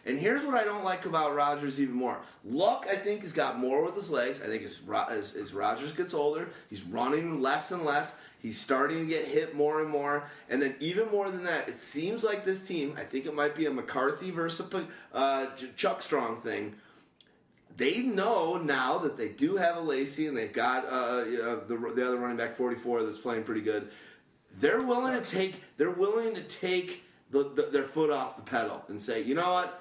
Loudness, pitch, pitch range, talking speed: -31 LUFS, 155 Hz, 140-190 Hz, 210 wpm